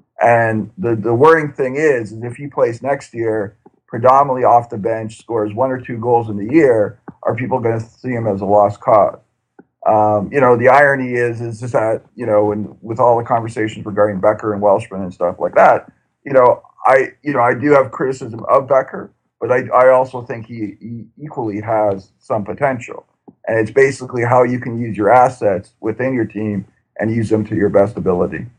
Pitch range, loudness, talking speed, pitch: 105-125 Hz, -15 LUFS, 205 wpm, 115 Hz